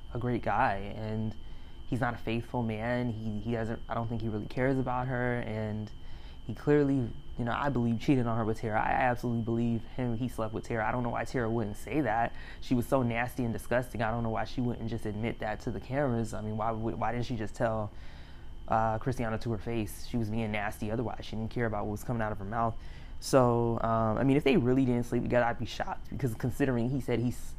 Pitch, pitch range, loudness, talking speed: 115 Hz, 110-120 Hz, -32 LUFS, 245 wpm